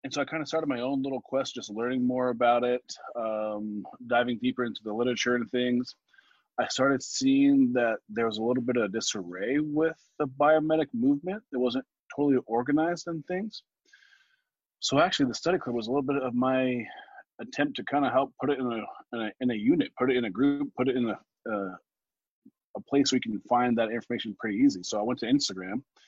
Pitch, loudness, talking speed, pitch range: 130 Hz, -28 LUFS, 215 wpm, 120-150 Hz